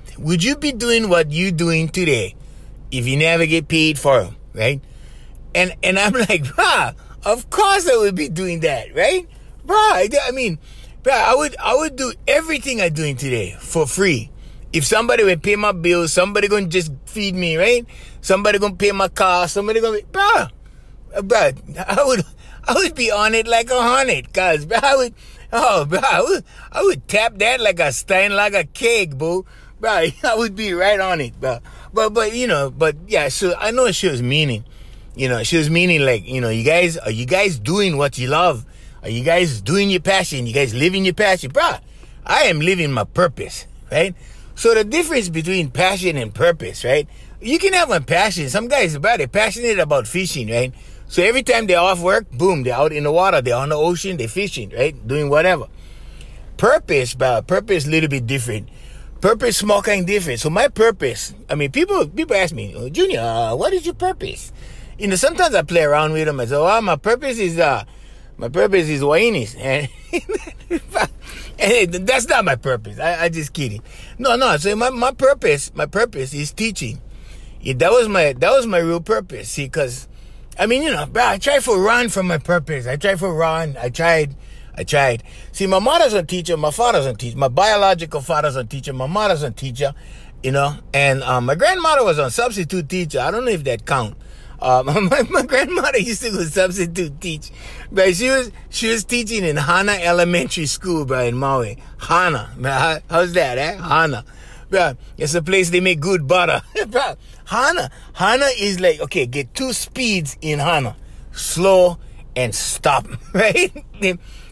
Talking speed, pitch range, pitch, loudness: 195 wpm, 140-215 Hz, 175 Hz, -17 LUFS